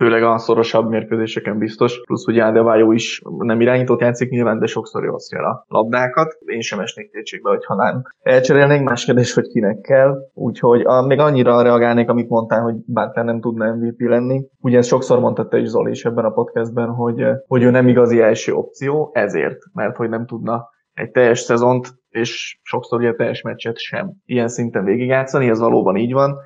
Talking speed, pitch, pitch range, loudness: 185 wpm, 120 Hz, 115-130 Hz, -16 LUFS